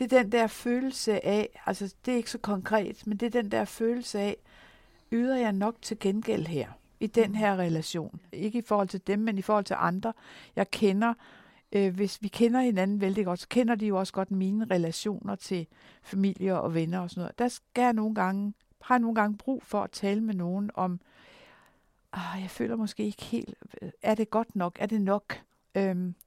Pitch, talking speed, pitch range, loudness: 205 Hz, 210 wpm, 190-225 Hz, -29 LUFS